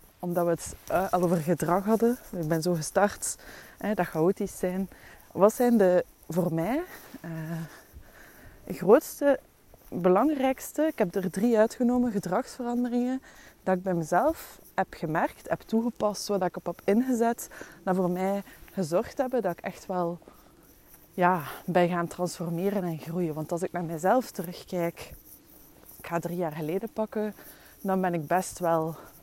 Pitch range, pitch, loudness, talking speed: 175-220 Hz, 185 Hz, -28 LUFS, 150 wpm